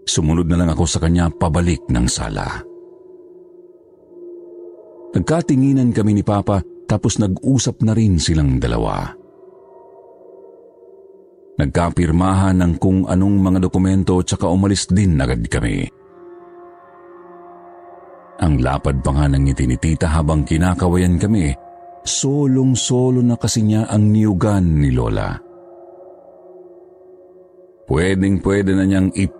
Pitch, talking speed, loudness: 105 Hz, 110 wpm, -17 LUFS